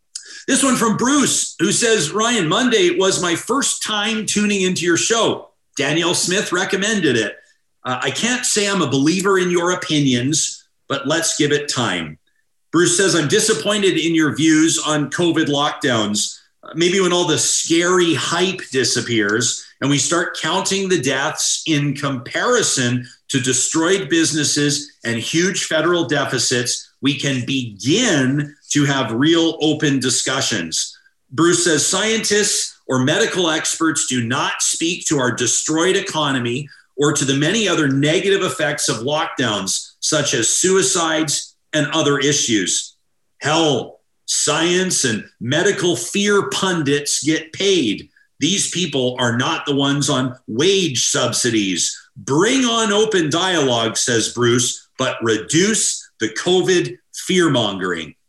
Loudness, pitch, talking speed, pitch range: -17 LUFS, 160 Hz, 135 wpm, 140-185 Hz